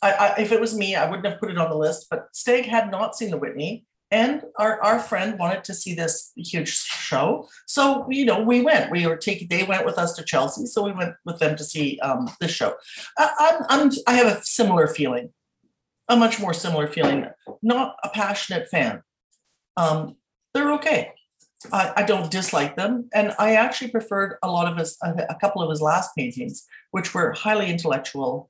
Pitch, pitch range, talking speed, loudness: 205 Hz, 170-230 Hz, 205 wpm, -22 LUFS